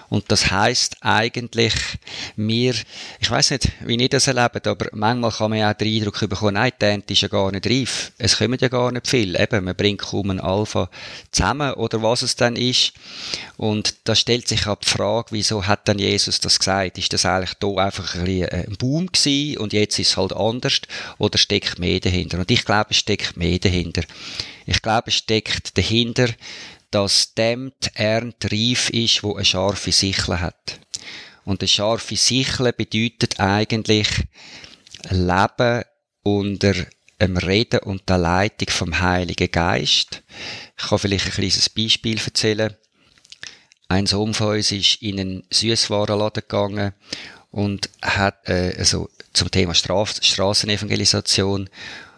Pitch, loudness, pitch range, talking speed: 105 Hz, -19 LUFS, 95-115 Hz, 160 wpm